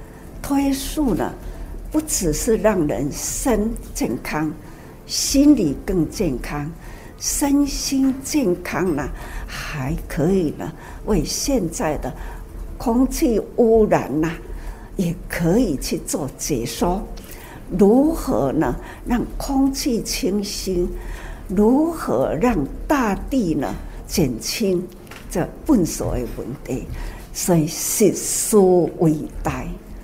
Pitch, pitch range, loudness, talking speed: 220 Hz, 175-275 Hz, -20 LUFS, 140 characters per minute